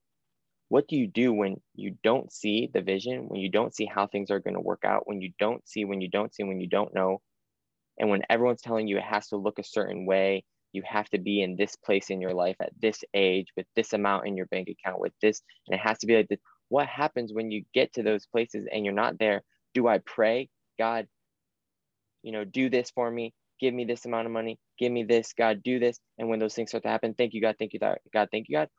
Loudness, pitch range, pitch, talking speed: -28 LUFS, 100-115 Hz, 110 Hz, 260 wpm